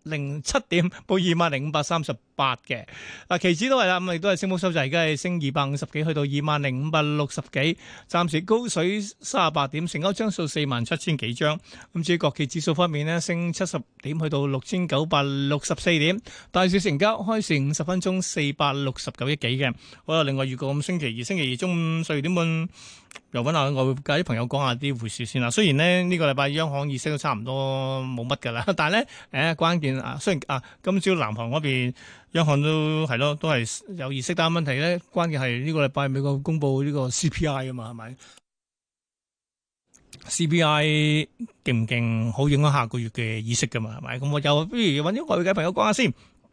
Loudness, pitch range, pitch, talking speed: -24 LUFS, 135-170 Hz, 150 Hz, 315 characters per minute